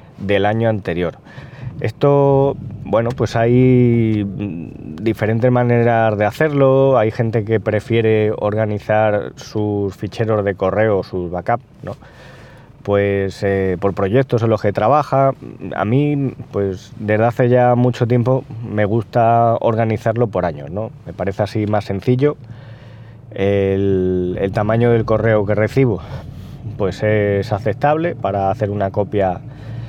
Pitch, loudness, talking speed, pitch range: 110 Hz, -17 LUFS, 130 wpm, 100-125 Hz